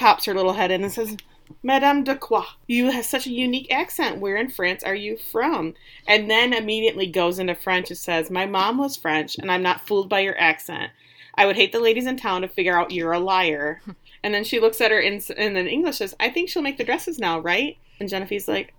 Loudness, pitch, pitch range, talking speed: -22 LUFS, 200 Hz, 180-230 Hz, 245 wpm